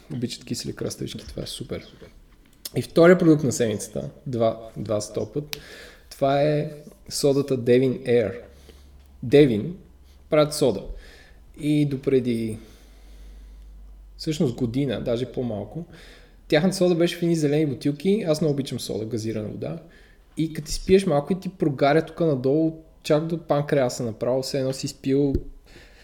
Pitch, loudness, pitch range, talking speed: 140 Hz, -23 LUFS, 115-155 Hz, 135 wpm